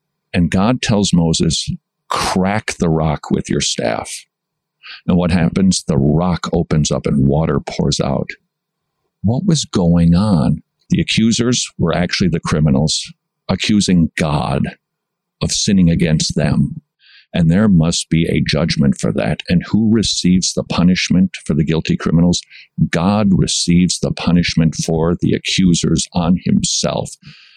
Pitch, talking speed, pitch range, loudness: 90 Hz, 135 wpm, 85-115 Hz, -15 LUFS